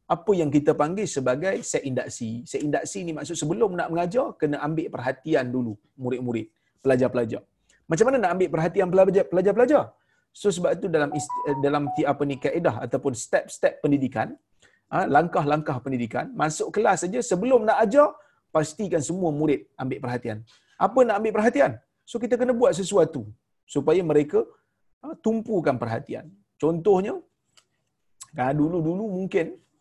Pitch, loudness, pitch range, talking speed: 160 Hz, -24 LUFS, 135-205 Hz, 140 wpm